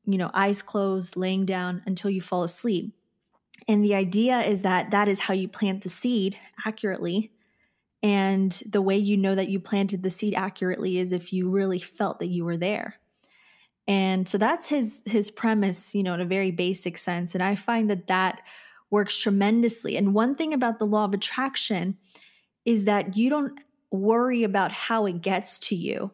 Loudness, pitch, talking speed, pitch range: -25 LUFS, 200 Hz, 190 wpm, 185-220 Hz